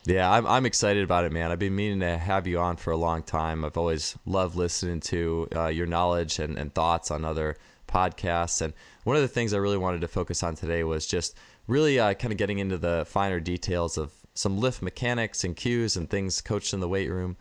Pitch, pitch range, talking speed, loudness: 90 Hz, 85-100 Hz, 235 wpm, -27 LUFS